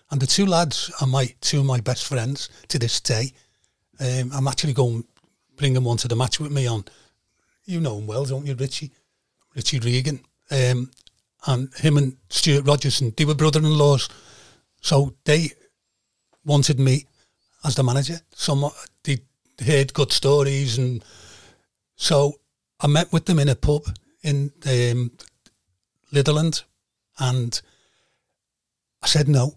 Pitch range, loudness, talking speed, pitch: 125-145 Hz, -22 LUFS, 150 wpm, 135 Hz